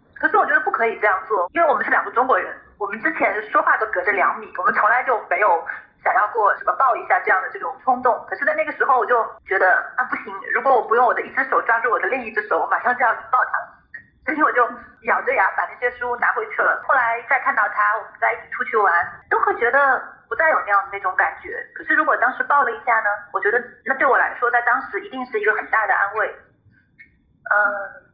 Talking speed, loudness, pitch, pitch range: 365 characters per minute, -19 LUFS, 245 Hz, 215-305 Hz